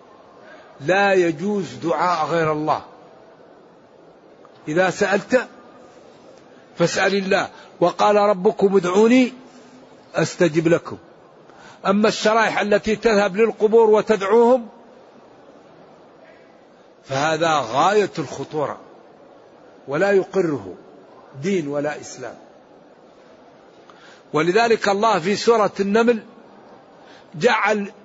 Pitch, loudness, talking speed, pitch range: 200 Hz, -19 LUFS, 75 wpm, 175-220 Hz